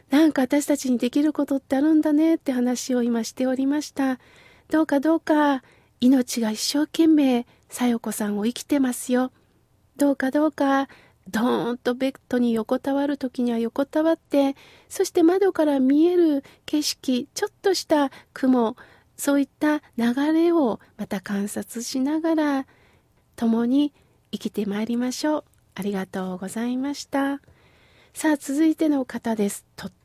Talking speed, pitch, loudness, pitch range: 295 characters per minute, 275 Hz, -23 LUFS, 240-300 Hz